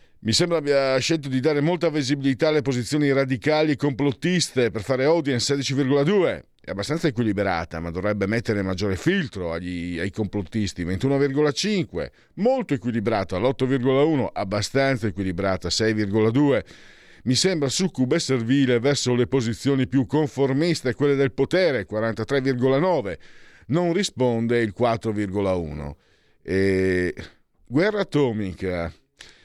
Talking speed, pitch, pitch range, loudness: 115 wpm, 130 Hz, 105-145 Hz, -23 LUFS